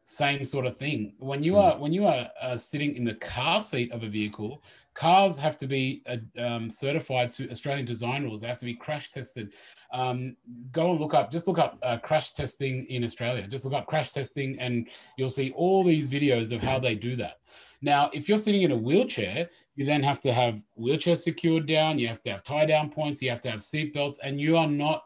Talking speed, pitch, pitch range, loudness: 230 wpm, 135 Hz, 120-155 Hz, -27 LUFS